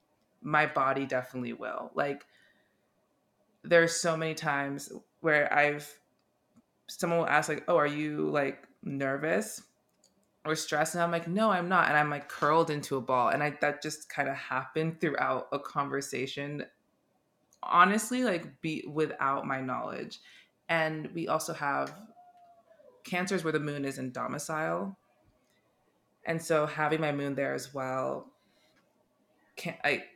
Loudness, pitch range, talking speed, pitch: -30 LUFS, 140-170 Hz, 145 wpm, 150 Hz